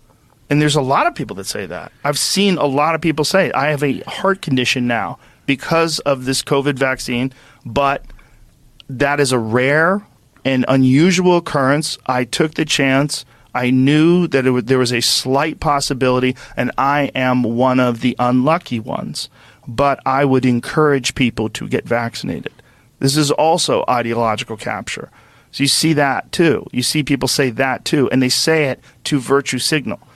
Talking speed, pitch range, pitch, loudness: 175 wpm, 125-150 Hz, 135 Hz, -16 LUFS